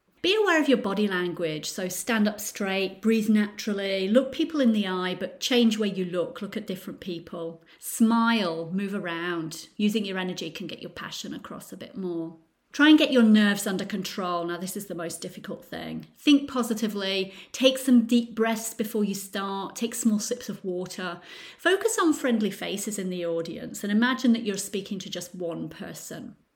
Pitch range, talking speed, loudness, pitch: 180-230 Hz, 190 wpm, -26 LUFS, 200 Hz